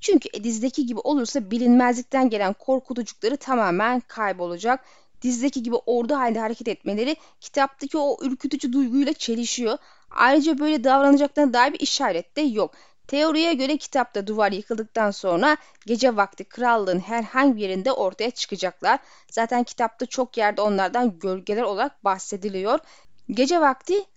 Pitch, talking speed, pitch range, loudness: 245 Hz, 130 wpm, 220-280 Hz, -23 LUFS